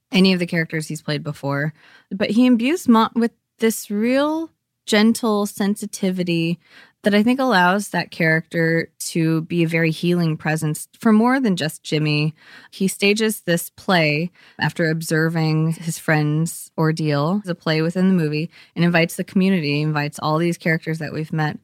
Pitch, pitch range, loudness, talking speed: 170 Hz, 160-205 Hz, -20 LUFS, 165 wpm